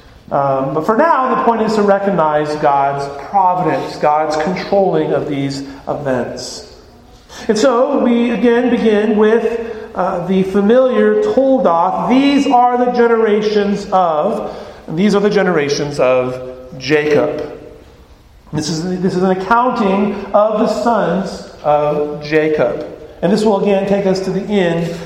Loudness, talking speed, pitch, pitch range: -14 LUFS, 140 wpm, 190 Hz, 150-220 Hz